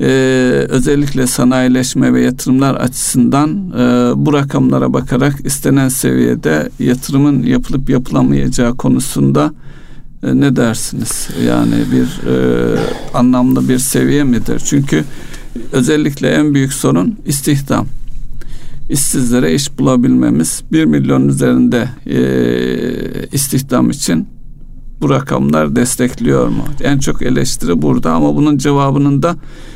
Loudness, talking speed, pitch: -13 LUFS, 105 wpm, 125 Hz